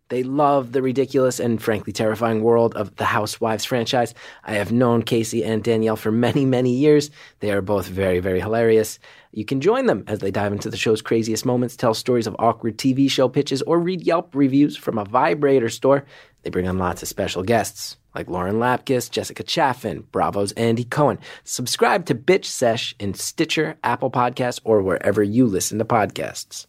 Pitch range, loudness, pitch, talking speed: 110-130 Hz, -20 LUFS, 115 Hz, 190 wpm